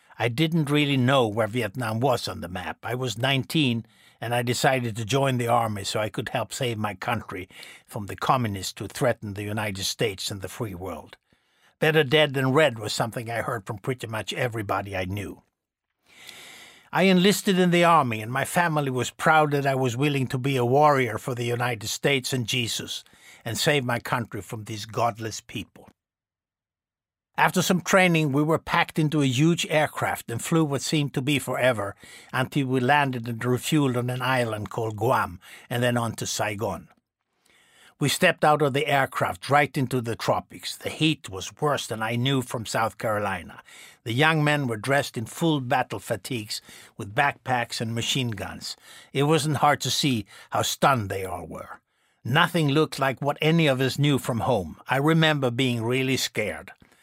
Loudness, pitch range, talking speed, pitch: -24 LUFS, 115-145 Hz, 185 wpm, 130 Hz